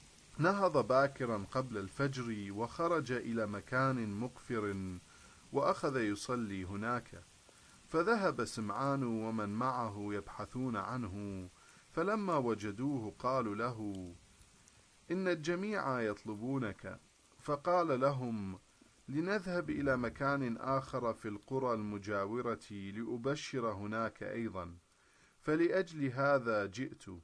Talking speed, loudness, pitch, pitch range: 85 wpm, -37 LUFS, 115 Hz, 105-135 Hz